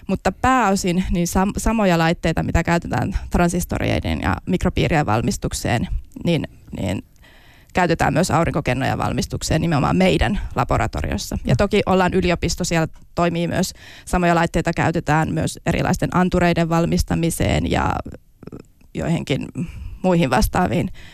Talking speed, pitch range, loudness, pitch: 110 wpm, 150-180 Hz, -20 LUFS, 170 Hz